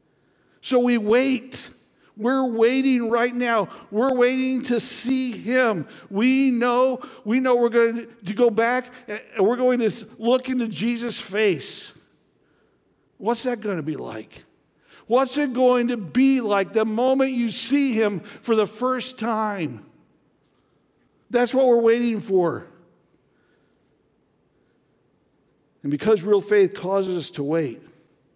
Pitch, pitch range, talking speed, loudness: 235 Hz, 215-255 Hz, 135 wpm, -22 LUFS